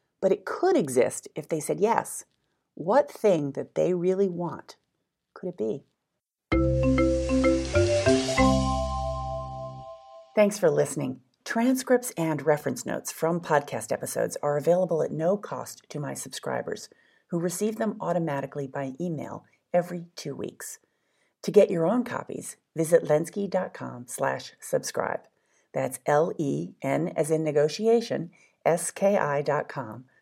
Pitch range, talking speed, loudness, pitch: 130-185 Hz, 120 wpm, -27 LUFS, 150 Hz